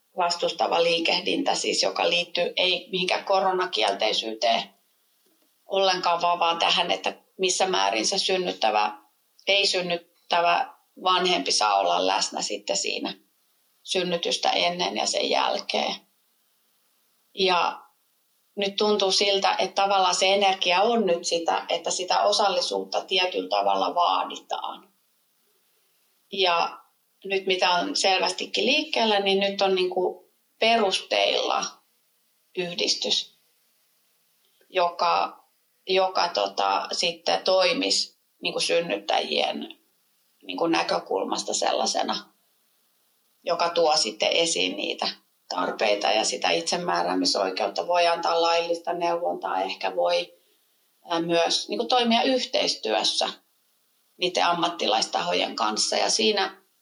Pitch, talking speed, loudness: 175 Hz, 100 wpm, -24 LUFS